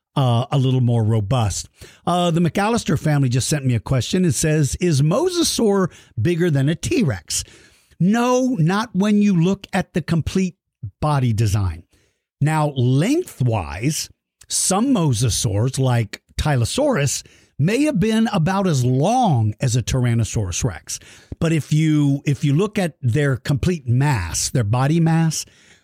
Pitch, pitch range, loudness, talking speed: 145 Hz, 120-175 Hz, -19 LUFS, 140 wpm